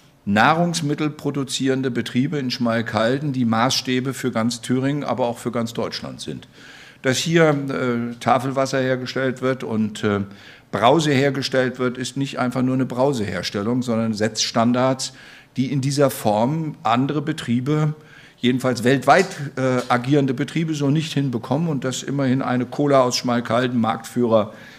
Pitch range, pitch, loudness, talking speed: 120-140 Hz, 130 Hz, -21 LUFS, 140 wpm